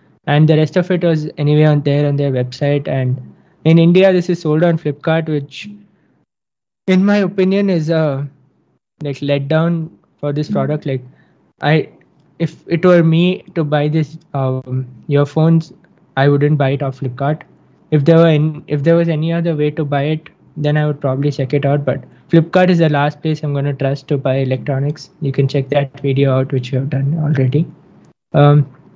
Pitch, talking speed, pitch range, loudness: 150 Hz, 195 wpm, 140-165 Hz, -15 LUFS